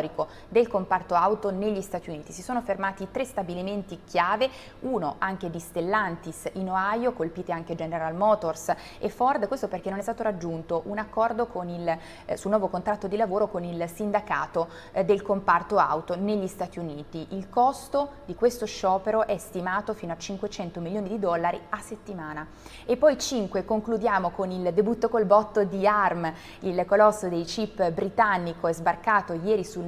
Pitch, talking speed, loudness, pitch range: 195 Hz, 170 wpm, -27 LUFS, 175-215 Hz